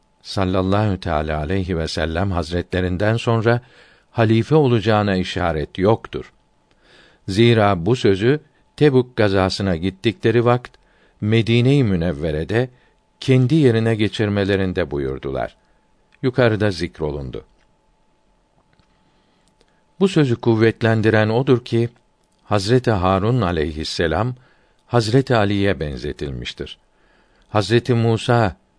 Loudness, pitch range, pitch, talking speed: -19 LUFS, 90-120 Hz, 105 Hz, 80 wpm